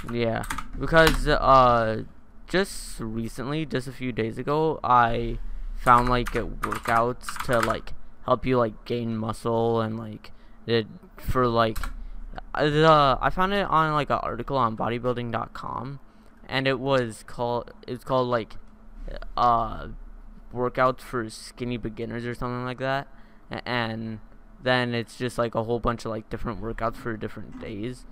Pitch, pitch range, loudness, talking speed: 120 Hz, 115-130 Hz, -25 LUFS, 145 wpm